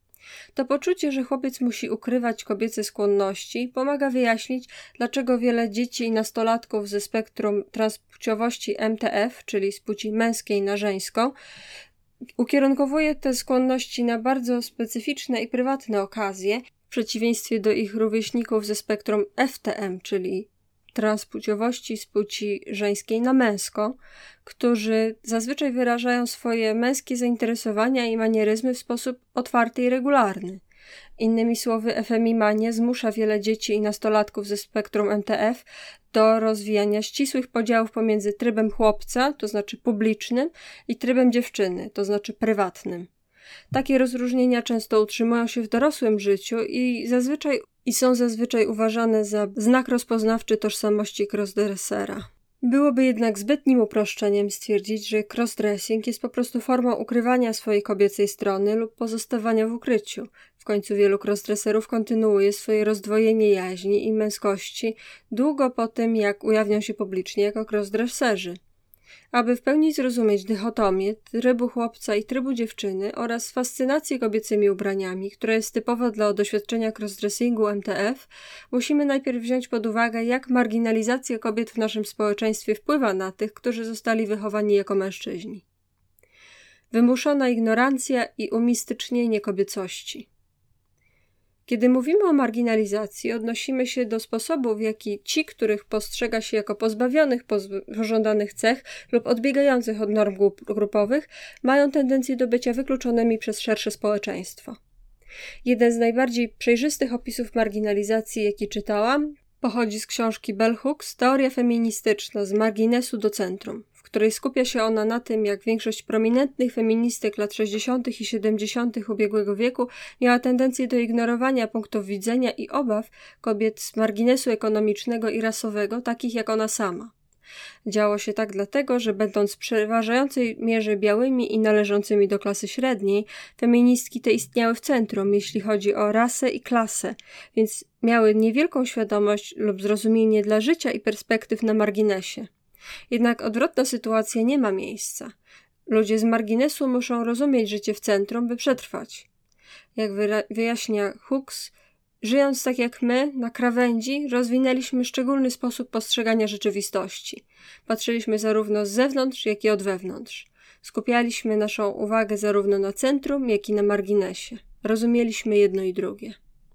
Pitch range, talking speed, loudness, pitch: 210-245 Hz, 130 wpm, -23 LUFS, 225 Hz